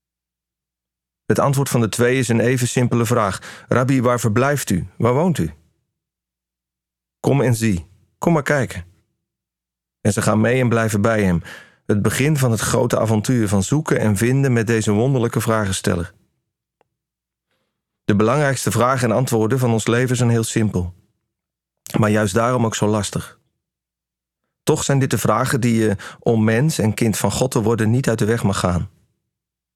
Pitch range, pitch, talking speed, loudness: 95-120 Hz, 110 Hz, 165 wpm, -18 LUFS